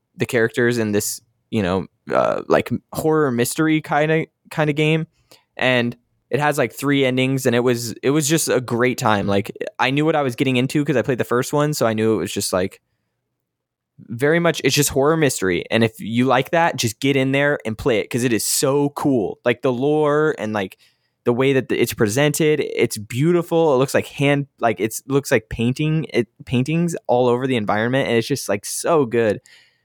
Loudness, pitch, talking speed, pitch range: -19 LUFS, 130 Hz, 215 wpm, 120-150 Hz